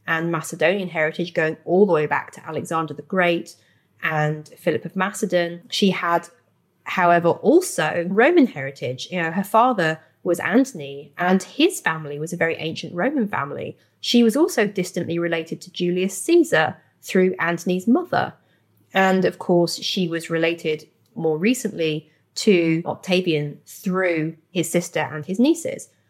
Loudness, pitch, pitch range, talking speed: -21 LUFS, 175 Hz, 160-190 Hz, 145 wpm